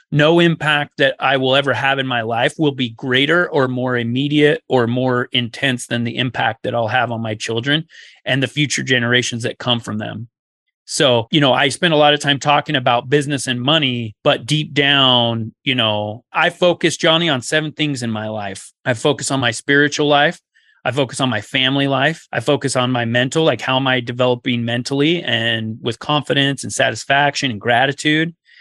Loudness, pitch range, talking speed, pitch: -16 LUFS, 120-150 Hz, 195 wpm, 135 Hz